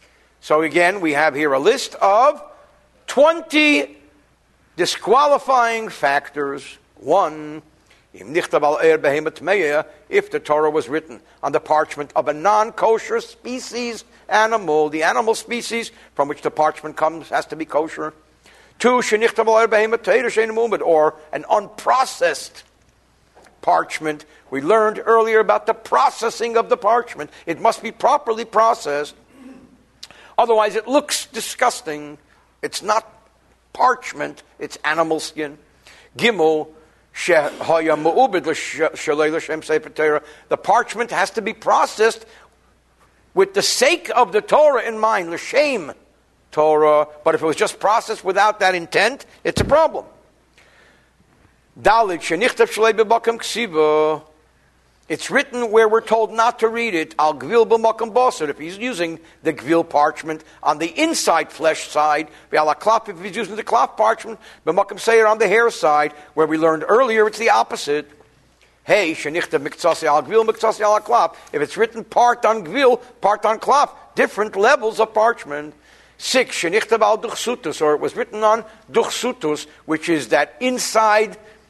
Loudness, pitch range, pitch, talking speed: -18 LUFS, 155-230 Hz, 215 Hz, 115 wpm